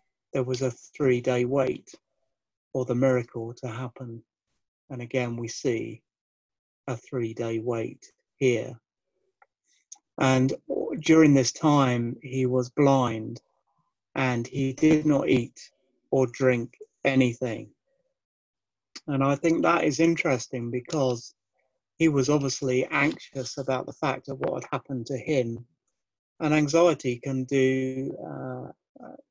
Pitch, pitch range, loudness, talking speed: 130 Hz, 125-150 Hz, -26 LUFS, 125 wpm